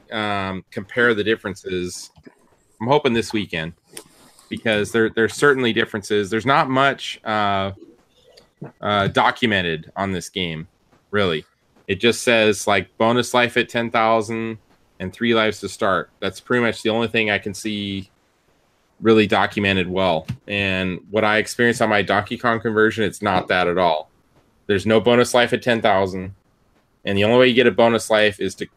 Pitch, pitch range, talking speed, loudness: 110 Hz, 100-115 Hz, 165 wpm, -19 LUFS